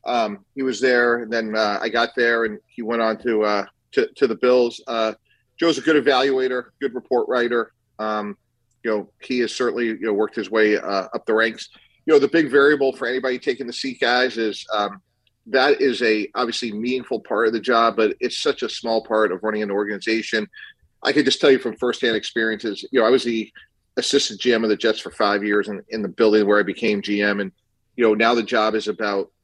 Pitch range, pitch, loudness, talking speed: 105-125 Hz, 115 Hz, -20 LUFS, 230 wpm